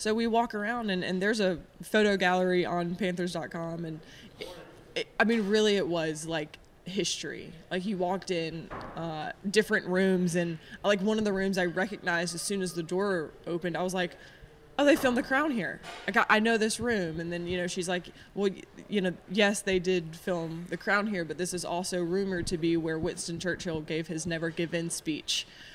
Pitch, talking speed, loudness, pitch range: 180 Hz, 210 wpm, -30 LUFS, 170-205 Hz